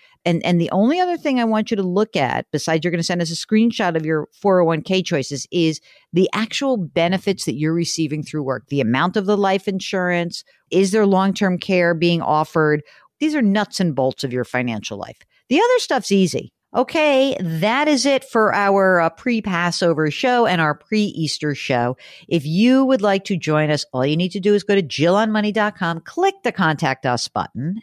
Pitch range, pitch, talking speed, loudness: 160-215 Hz, 180 Hz, 205 wpm, -19 LUFS